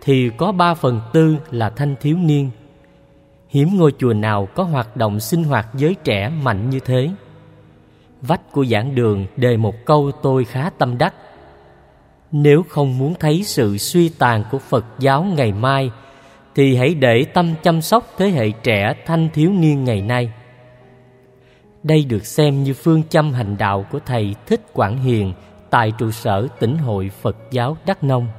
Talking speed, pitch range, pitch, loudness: 175 wpm, 115-150 Hz, 130 Hz, -17 LUFS